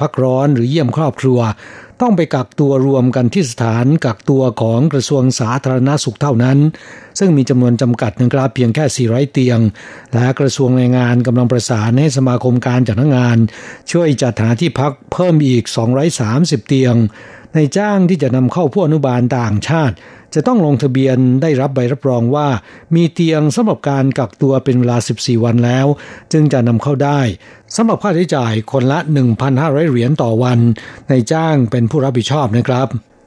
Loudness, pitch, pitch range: -14 LUFS, 130 Hz, 120-145 Hz